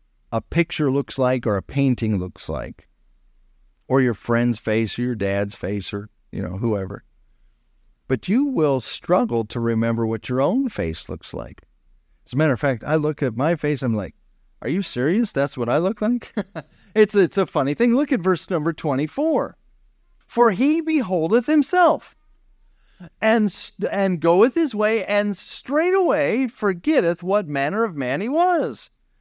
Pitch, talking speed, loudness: 150 Hz, 170 wpm, -21 LUFS